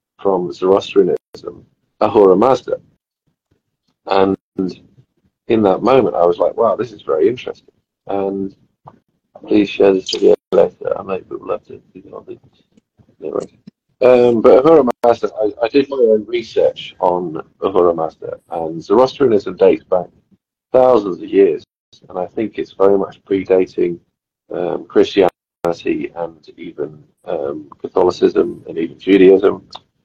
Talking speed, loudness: 130 wpm, -15 LUFS